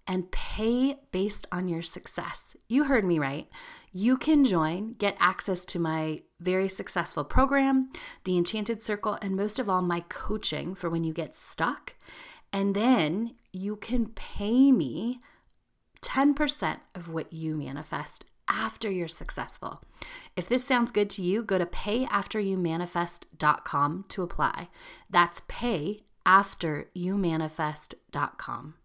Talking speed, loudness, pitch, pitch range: 125 wpm, -27 LUFS, 195 Hz, 170-235 Hz